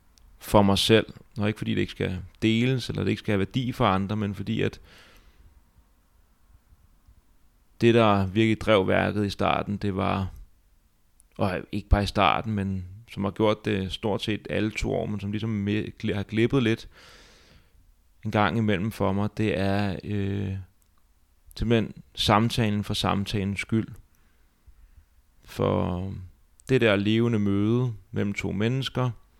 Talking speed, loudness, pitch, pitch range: 145 wpm, -26 LUFS, 100 Hz, 90-110 Hz